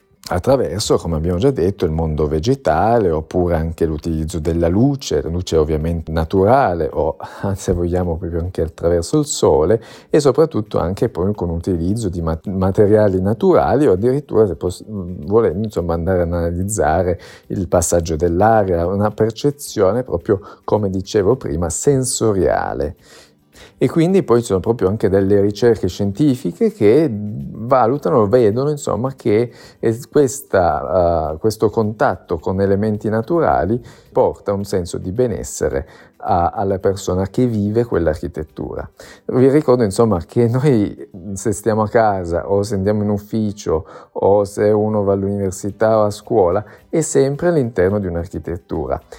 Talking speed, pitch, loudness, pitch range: 135 wpm, 100 Hz, -17 LUFS, 90-115 Hz